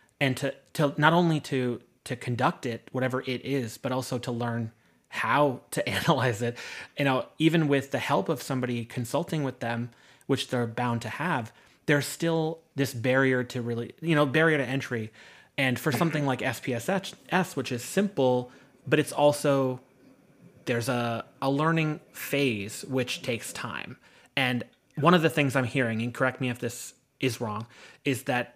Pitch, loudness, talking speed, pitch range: 130 Hz, -28 LUFS, 170 wpm, 125-145 Hz